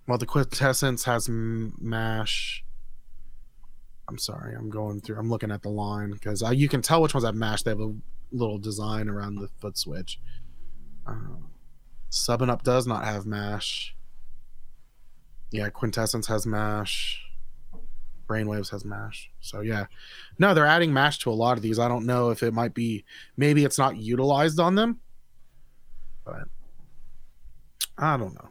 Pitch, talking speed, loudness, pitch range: 115 Hz, 160 wpm, -26 LUFS, 105-125 Hz